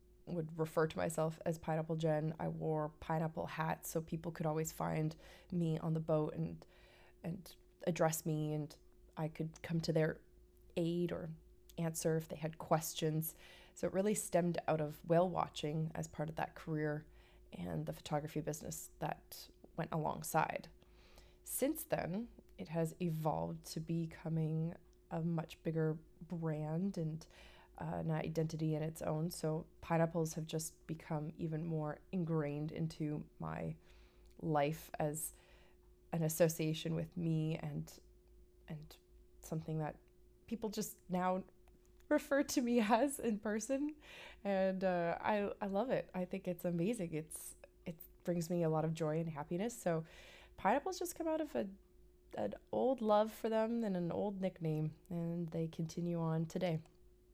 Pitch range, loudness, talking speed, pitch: 155-180 Hz, -40 LUFS, 150 wpm, 165 Hz